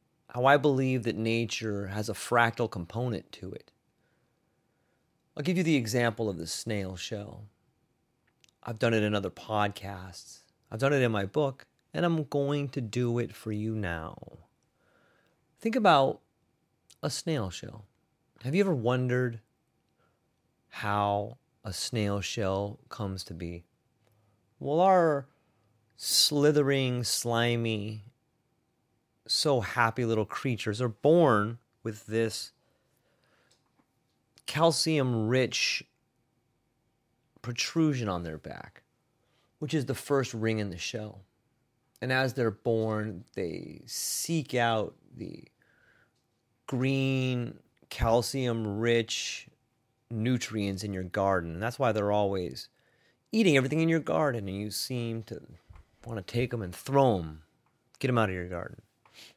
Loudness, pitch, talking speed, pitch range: -29 LUFS, 115 Hz, 125 wpm, 105-130 Hz